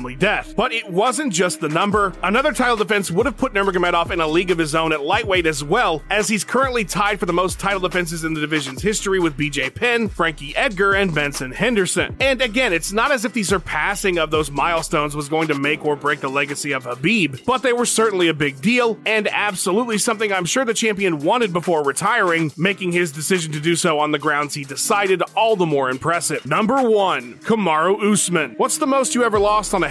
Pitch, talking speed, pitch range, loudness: 180 Hz, 225 wpm, 155-215 Hz, -19 LUFS